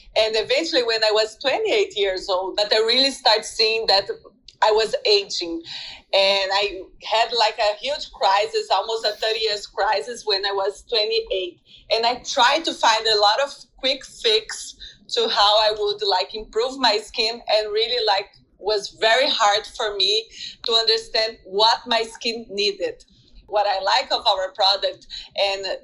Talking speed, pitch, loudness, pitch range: 165 wpm, 225 Hz, -20 LUFS, 205-290 Hz